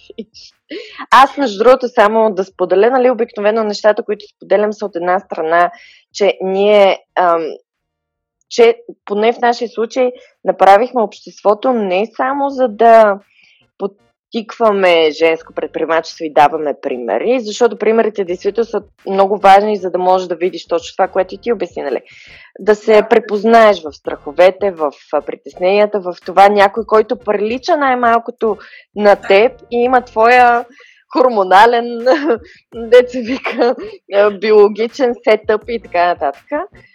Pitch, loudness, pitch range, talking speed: 210 Hz, -13 LUFS, 190-240 Hz, 125 wpm